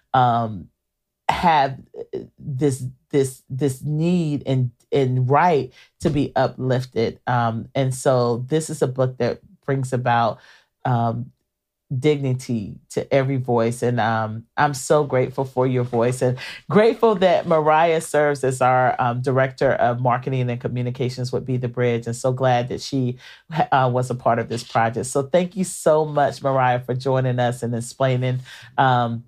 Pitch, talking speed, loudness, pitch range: 130 Hz, 155 wpm, -21 LUFS, 120-140 Hz